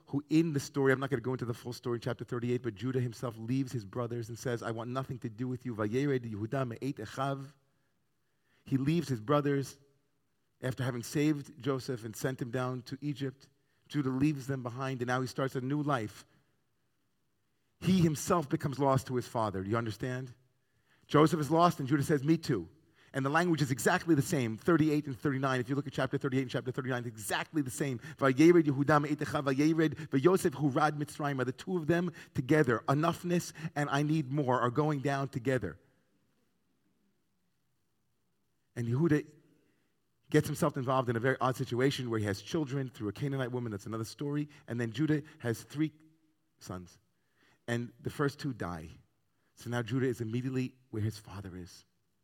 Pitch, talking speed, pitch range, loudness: 135 Hz, 180 wpm, 125-150 Hz, -32 LUFS